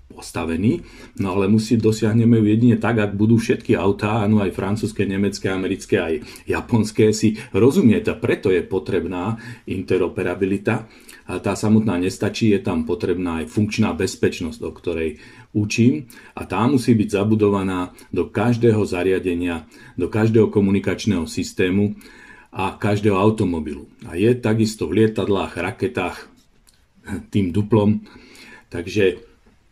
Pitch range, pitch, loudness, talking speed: 100-110 Hz, 105 Hz, -20 LUFS, 125 wpm